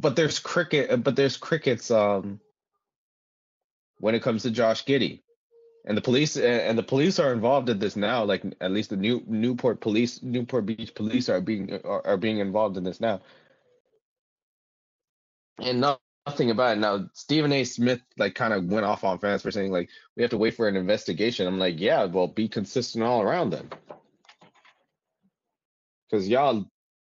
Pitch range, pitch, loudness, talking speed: 105-135 Hz, 115 Hz, -25 LUFS, 175 wpm